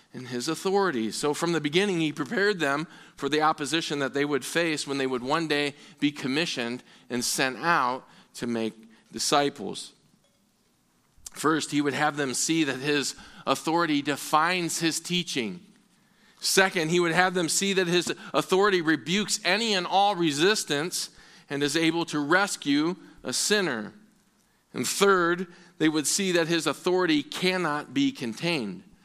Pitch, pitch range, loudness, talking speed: 160 Hz, 145-185 Hz, -26 LUFS, 150 wpm